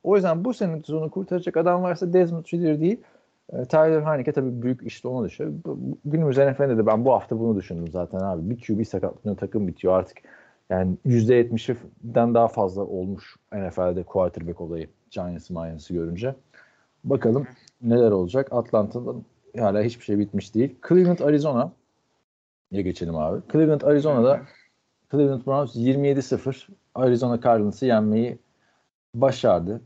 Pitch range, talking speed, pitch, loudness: 100-145 Hz, 135 wpm, 120 Hz, -23 LUFS